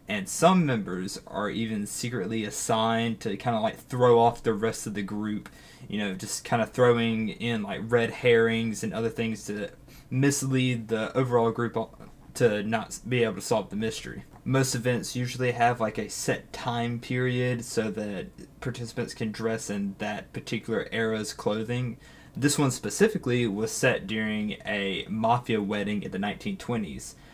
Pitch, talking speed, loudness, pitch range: 115 Hz, 165 wpm, -28 LUFS, 110-125 Hz